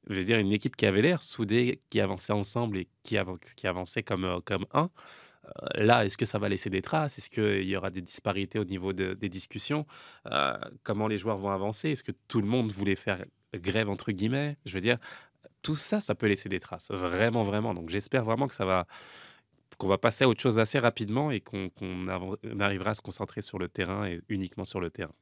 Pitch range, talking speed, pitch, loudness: 95-115 Hz, 235 wpm, 105 Hz, -30 LUFS